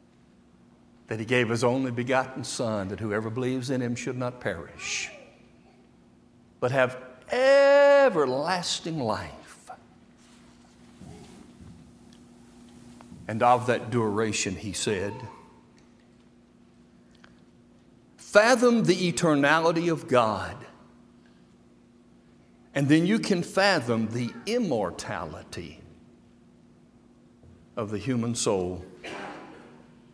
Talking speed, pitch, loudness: 80 wpm, 120 Hz, -25 LUFS